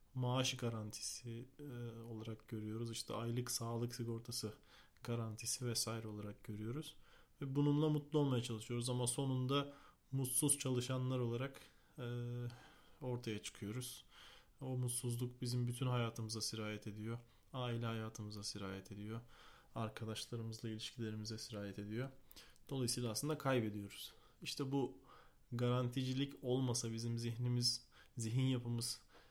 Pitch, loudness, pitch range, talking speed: 120 Hz, -42 LUFS, 110-130 Hz, 105 wpm